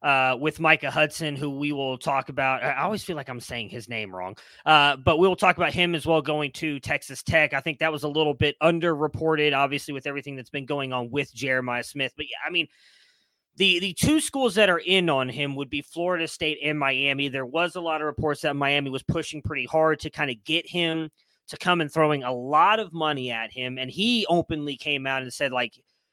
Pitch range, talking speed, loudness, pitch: 135-160 Hz, 235 wpm, -24 LUFS, 150 Hz